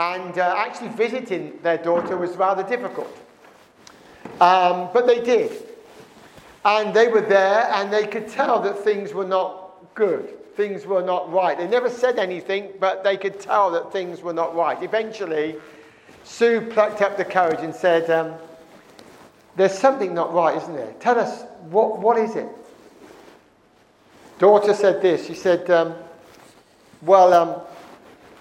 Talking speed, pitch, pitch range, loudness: 150 wpm, 195 Hz, 175-225 Hz, -20 LUFS